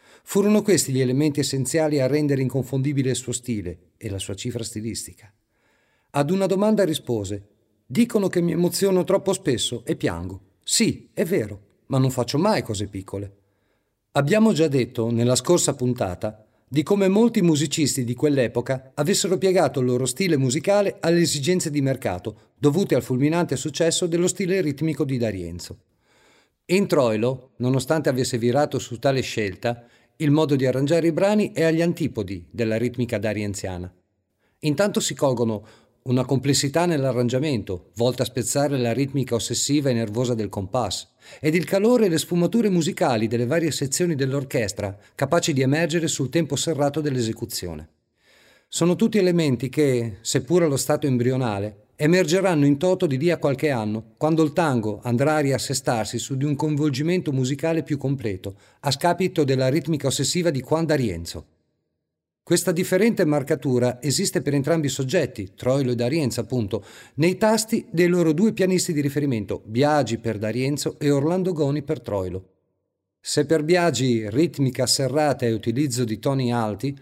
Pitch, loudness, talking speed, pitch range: 135 Hz, -22 LUFS, 155 wpm, 115-165 Hz